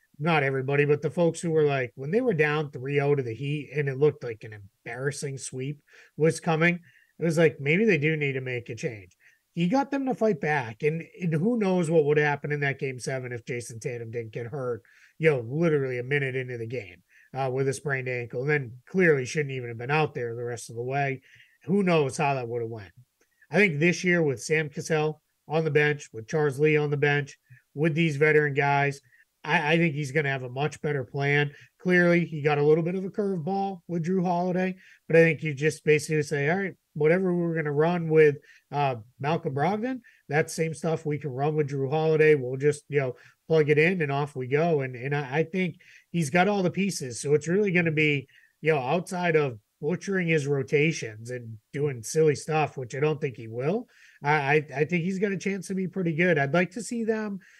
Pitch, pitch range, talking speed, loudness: 150 Hz, 135-165 Hz, 230 wpm, -26 LUFS